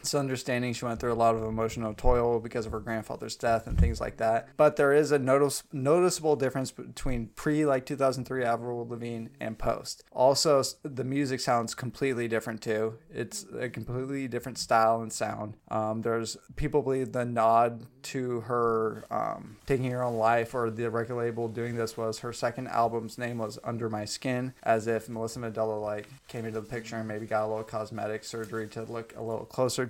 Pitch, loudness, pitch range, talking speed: 115 Hz, -30 LUFS, 115-130 Hz, 200 wpm